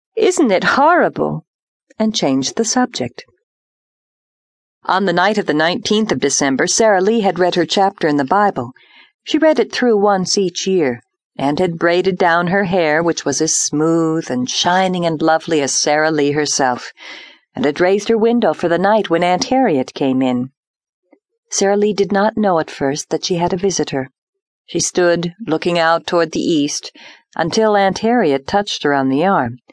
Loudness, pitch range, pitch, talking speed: -15 LUFS, 150-210 Hz, 175 Hz, 180 wpm